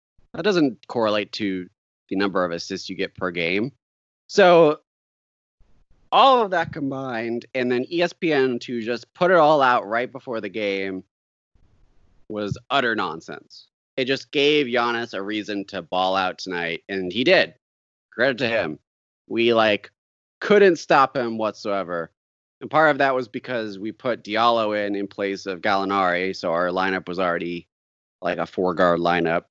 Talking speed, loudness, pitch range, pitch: 160 wpm, -22 LUFS, 90-120 Hz, 100 Hz